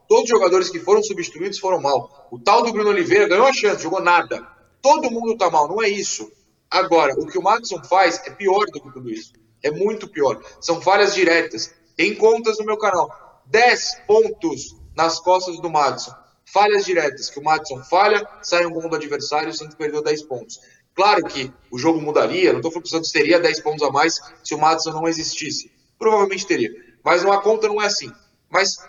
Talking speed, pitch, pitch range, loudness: 205 wpm, 190 Hz, 160-230 Hz, -19 LUFS